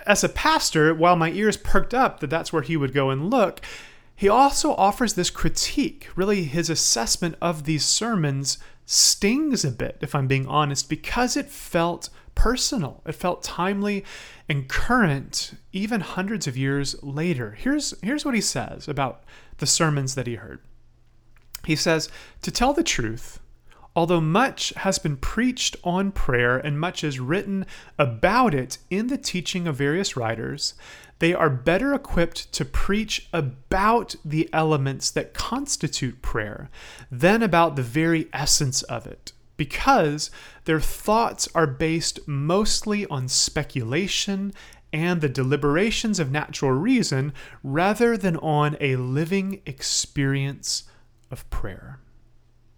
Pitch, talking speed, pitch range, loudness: 165 Hz, 140 wpm, 140-200 Hz, -23 LUFS